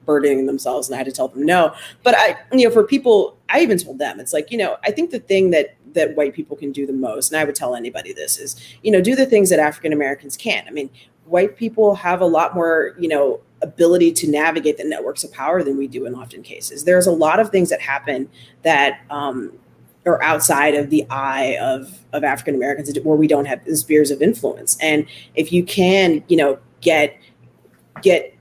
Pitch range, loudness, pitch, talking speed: 140-180 Hz, -17 LUFS, 155 Hz, 225 wpm